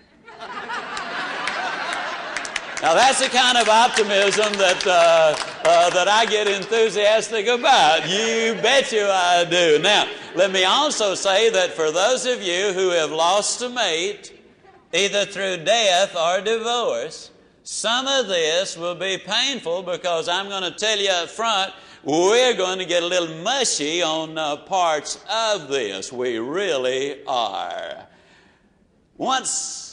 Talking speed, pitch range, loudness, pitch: 135 wpm, 175-250 Hz, -19 LUFS, 205 Hz